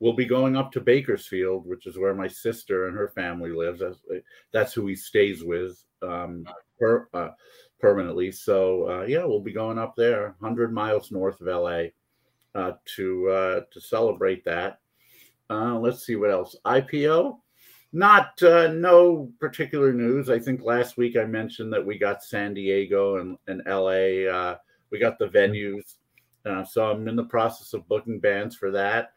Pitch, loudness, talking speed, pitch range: 115 Hz, -24 LUFS, 175 wpm, 95-135 Hz